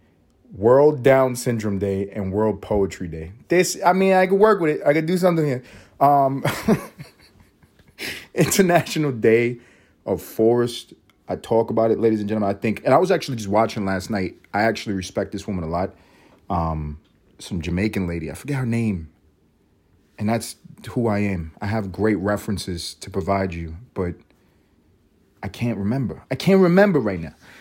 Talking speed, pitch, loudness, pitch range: 170 wpm, 105 Hz, -21 LUFS, 95-125 Hz